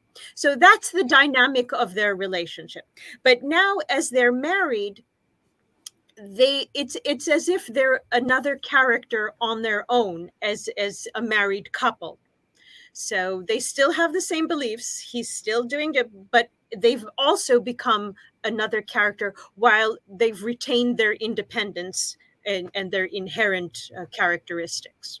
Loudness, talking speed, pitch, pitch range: -22 LUFS, 135 wpm, 230 Hz, 205-265 Hz